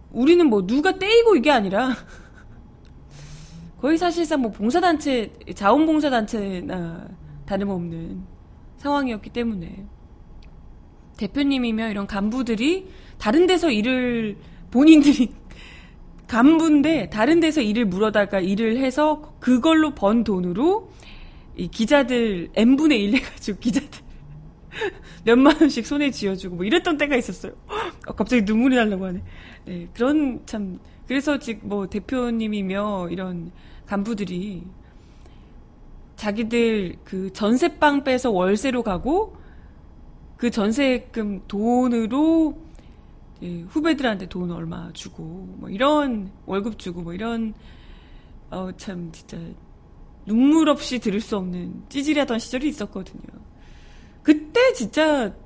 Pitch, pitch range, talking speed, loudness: 230 Hz, 195-285 Hz, 245 characters per minute, -21 LUFS